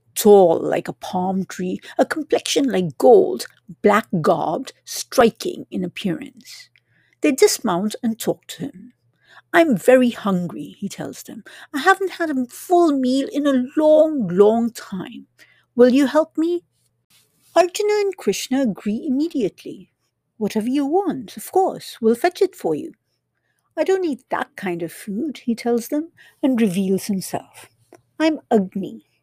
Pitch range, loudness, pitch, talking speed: 200-310 Hz, -19 LUFS, 245 Hz, 150 wpm